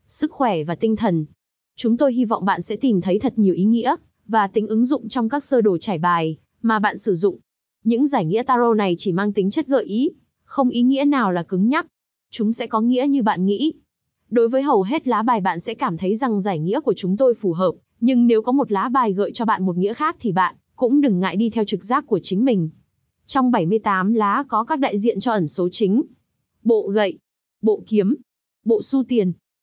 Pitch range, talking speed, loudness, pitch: 195-255 Hz, 235 wpm, -20 LUFS, 220 Hz